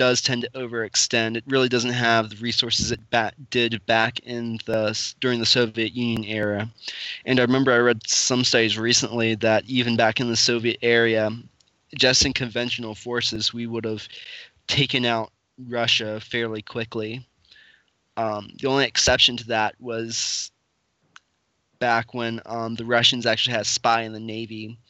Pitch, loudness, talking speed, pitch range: 115 Hz, -22 LUFS, 160 wpm, 110-120 Hz